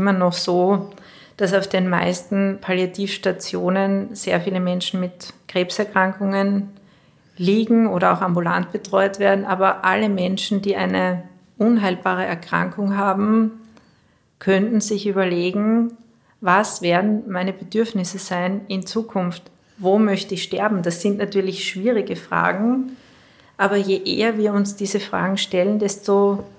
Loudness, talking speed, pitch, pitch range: -20 LUFS, 125 wpm, 195 Hz, 185-205 Hz